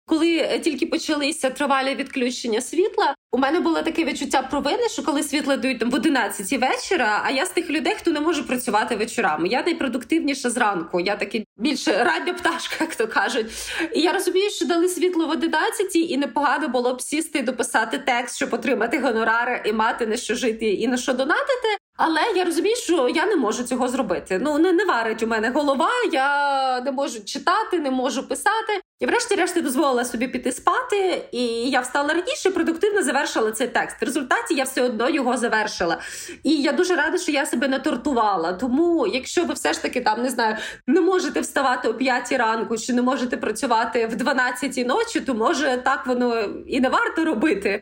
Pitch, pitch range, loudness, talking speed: 280 Hz, 245-330 Hz, -22 LUFS, 190 wpm